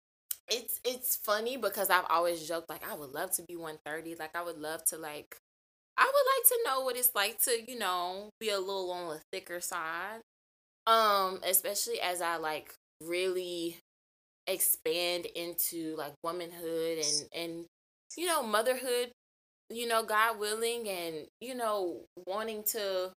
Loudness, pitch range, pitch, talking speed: -32 LUFS, 170-225 Hz, 185 Hz, 160 wpm